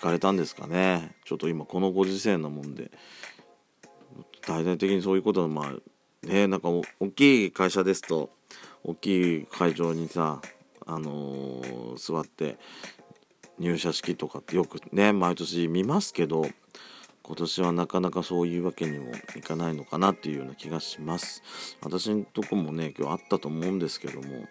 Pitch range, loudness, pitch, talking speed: 80-95 Hz, -28 LUFS, 85 Hz, 330 characters per minute